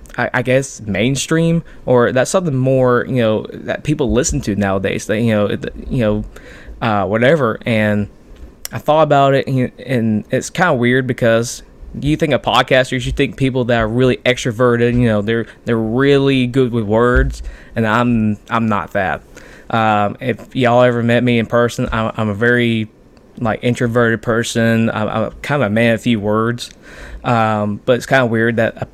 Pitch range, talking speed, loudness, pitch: 110-130 Hz, 180 wpm, -15 LUFS, 120 Hz